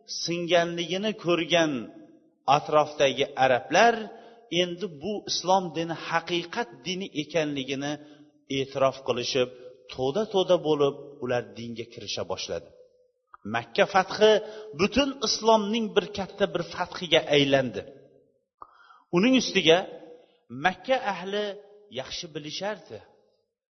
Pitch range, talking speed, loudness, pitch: 150-220 Hz, 90 wpm, -26 LUFS, 180 Hz